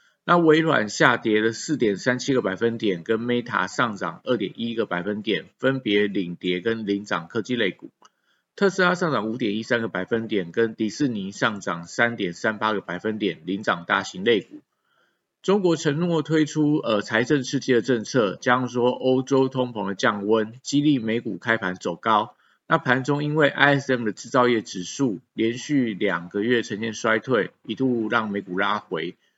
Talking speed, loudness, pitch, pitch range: 270 characters per minute, -23 LUFS, 115 Hz, 105-135 Hz